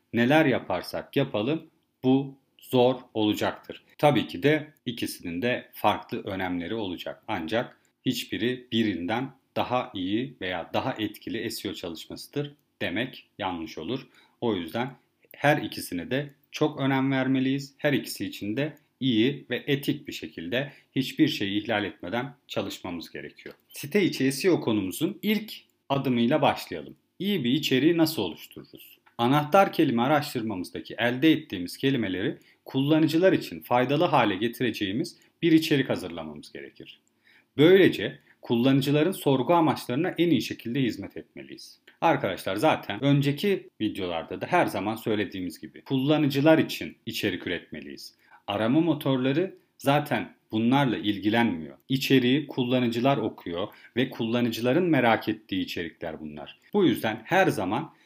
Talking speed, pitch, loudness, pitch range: 120 wpm, 135 Hz, -26 LUFS, 120-150 Hz